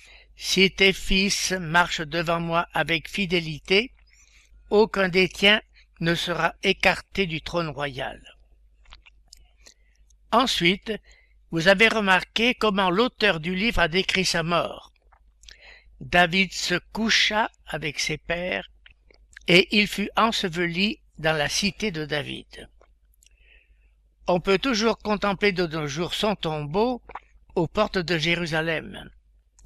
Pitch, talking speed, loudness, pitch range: 180 Hz, 115 wpm, -23 LUFS, 160-200 Hz